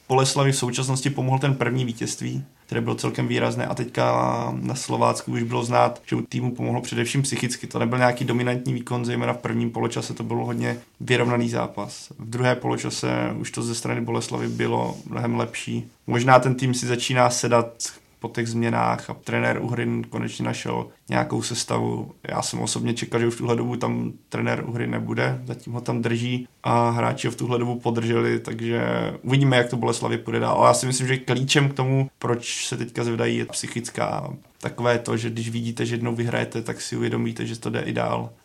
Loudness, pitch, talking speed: -24 LUFS, 115 Hz, 195 wpm